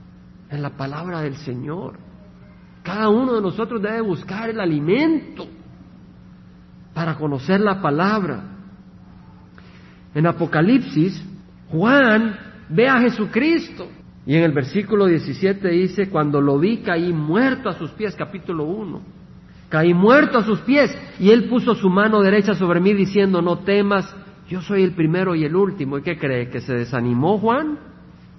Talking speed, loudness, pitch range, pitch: 145 wpm, -19 LUFS, 160-215 Hz, 185 Hz